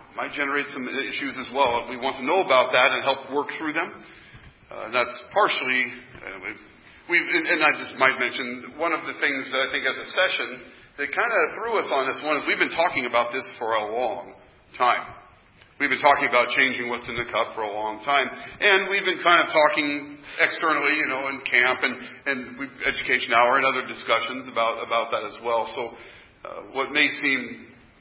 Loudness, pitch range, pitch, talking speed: -23 LUFS, 120-145 Hz, 135 Hz, 210 wpm